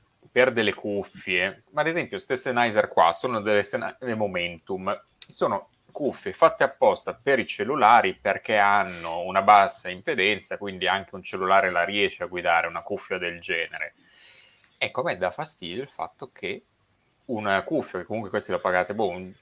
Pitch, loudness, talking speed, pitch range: 105 Hz, -24 LUFS, 165 wpm, 90-120 Hz